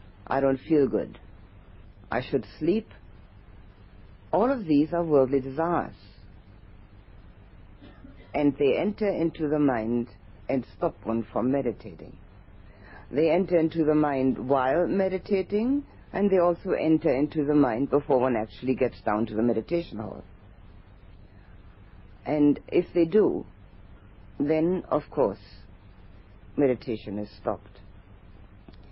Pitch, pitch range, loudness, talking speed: 110 Hz, 100-150 Hz, -26 LUFS, 120 wpm